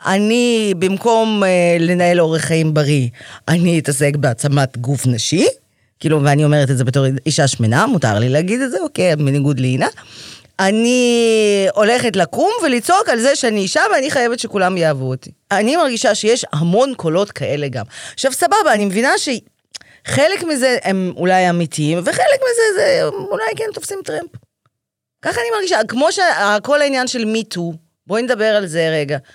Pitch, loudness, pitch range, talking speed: 195 Hz, -15 LUFS, 155-250 Hz, 155 wpm